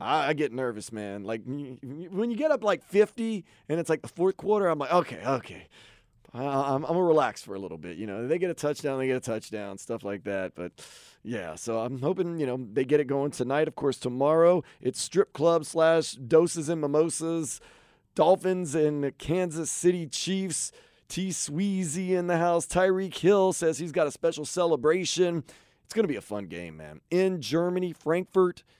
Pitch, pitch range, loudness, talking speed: 155 Hz, 125-175 Hz, -27 LUFS, 195 wpm